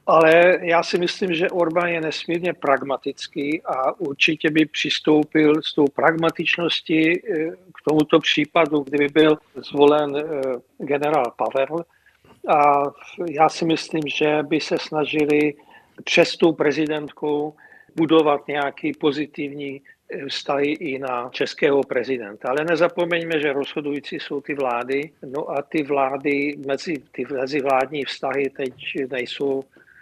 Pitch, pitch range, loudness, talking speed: 150 Hz, 140-160 Hz, -21 LUFS, 120 wpm